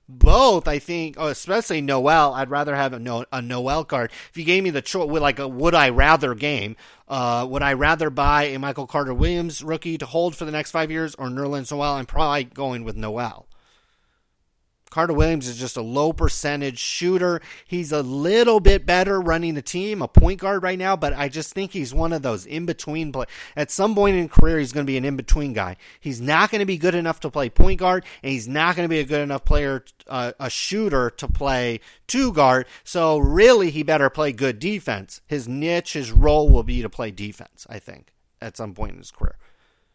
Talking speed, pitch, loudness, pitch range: 220 wpm, 145 Hz, -21 LUFS, 130-165 Hz